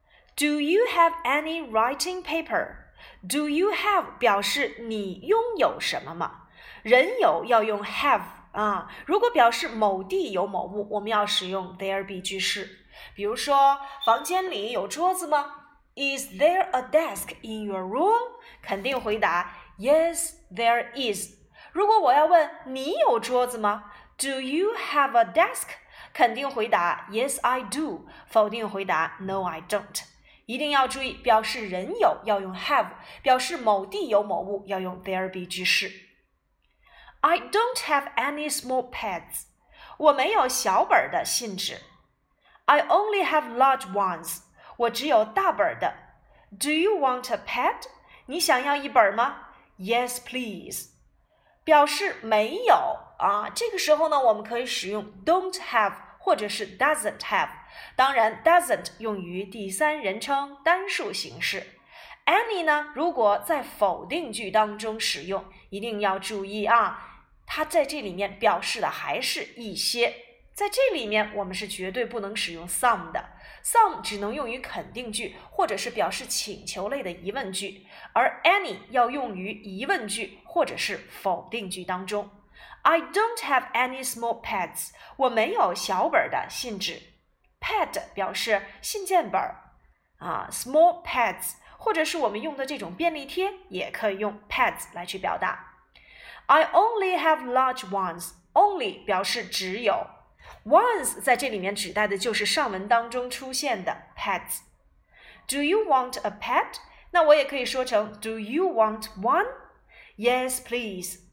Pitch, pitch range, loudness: 250 Hz, 205-320 Hz, -25 LUFS